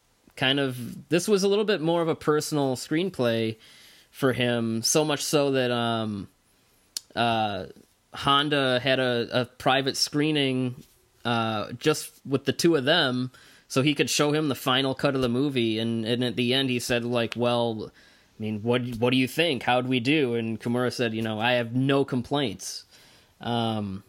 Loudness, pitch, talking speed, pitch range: -25 LUFS, 125 Hz, 180 wpm, 115-140 Hz